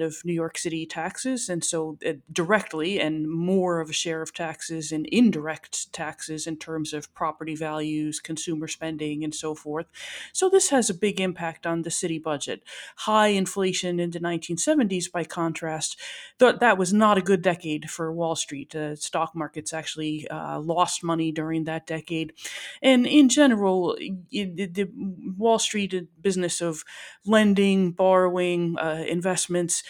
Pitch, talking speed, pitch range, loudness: 170 Hz, 155 wpm, 160-190 Hz, -25 LUFS